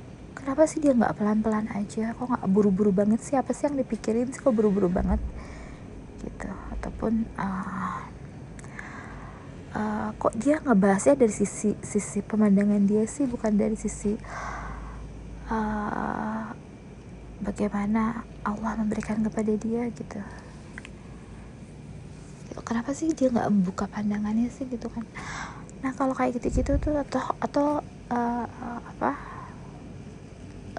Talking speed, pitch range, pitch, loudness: 115 wpm, 210-245 Hz, 220 Hz, -27 LUFS